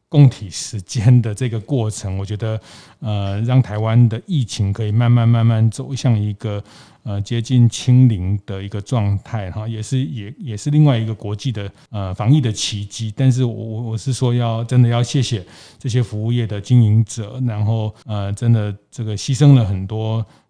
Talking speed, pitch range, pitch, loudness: 270 characters per minute, 105-125 Hz, 115 Hz, -18 LUFS